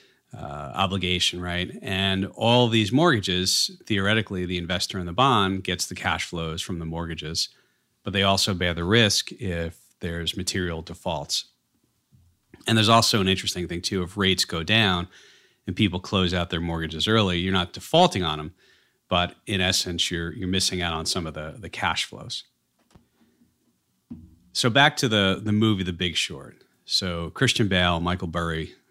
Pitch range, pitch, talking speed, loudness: 85-105 Hz, 95 Hz, 170 wpm, -23 LUFS